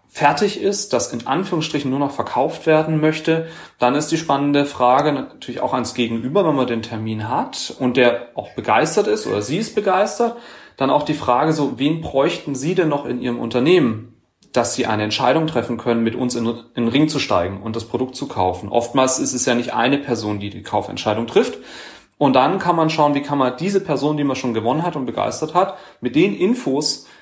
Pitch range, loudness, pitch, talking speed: 120-155 Hz, -19 LUFS, 135 Hz, 210 wpm